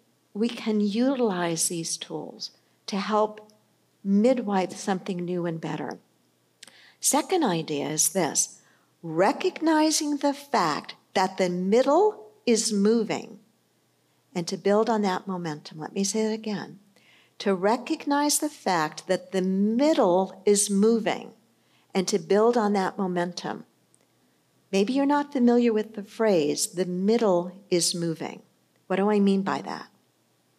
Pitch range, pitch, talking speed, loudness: 185-230 Hz, 200 Hz, 130 wpm, -25 LUFS